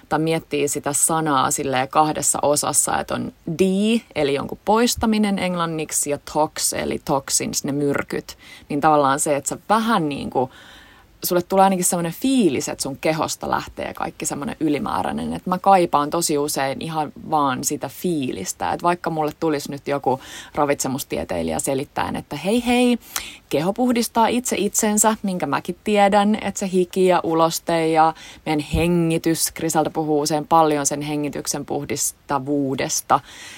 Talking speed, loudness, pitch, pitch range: 145 wpm, -20 LUFS, 160 Hz, 145-195 Hz